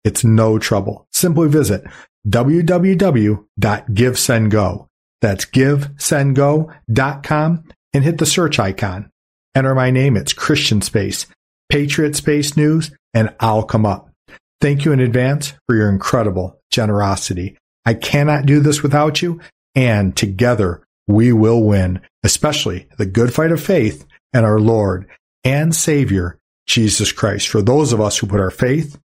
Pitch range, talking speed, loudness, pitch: 105-150 Hz, 140 wpm, -16 LUFS, 120 Hz